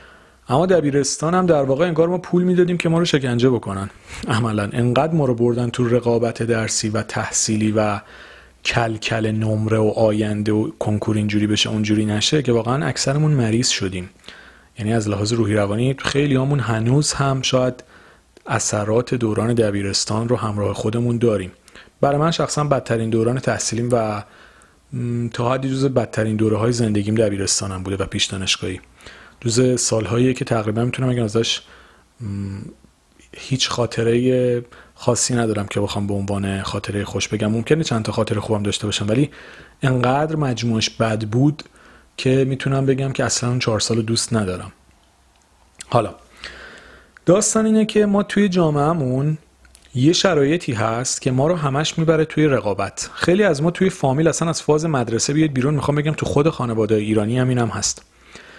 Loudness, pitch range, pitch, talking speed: -19 LUFS, 110-135 Hz, 120 Hz, 155 wpm